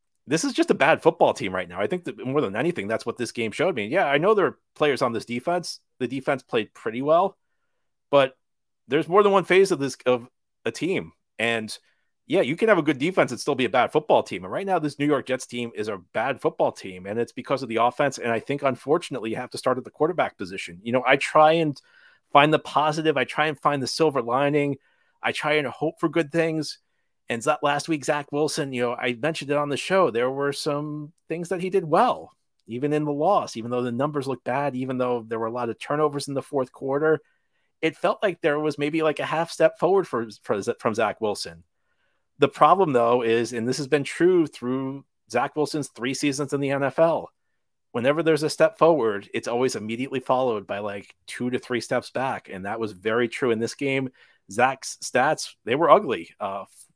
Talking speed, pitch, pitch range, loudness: 225 wpm, 140 Hz, 120-155 Hz, -24 LUFS